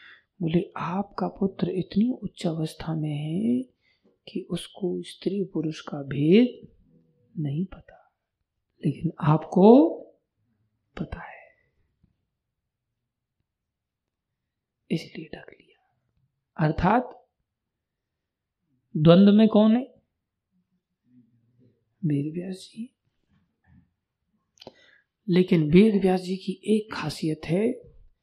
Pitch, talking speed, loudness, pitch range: 170 Hz, 85 wpm, -24 LUFS, 135-190 Hz